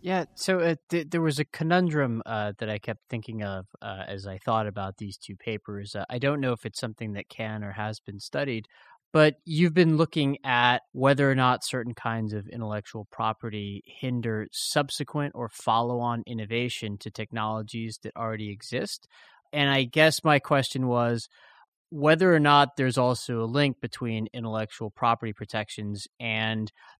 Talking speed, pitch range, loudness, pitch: 170 wpm, 110-140 Hz, -27 LUFS, 115 Hz